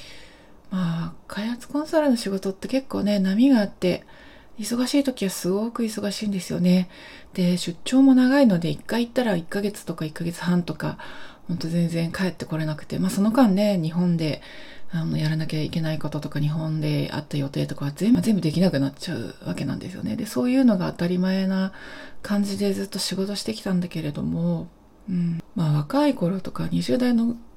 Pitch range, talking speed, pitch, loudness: 165-225 Hz, 375 characters per minute, 190 Hz, -24 LUFS